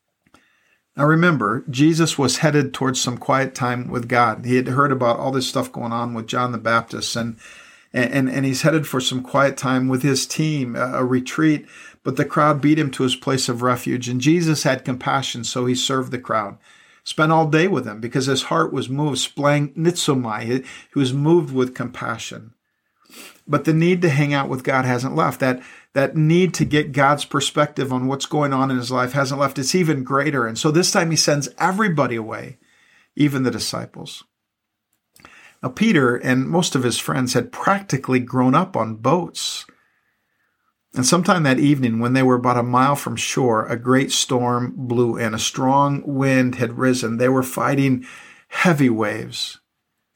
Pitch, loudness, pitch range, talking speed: 135 Hz, -19 LUFS, 125-145 Hz, 185 wpm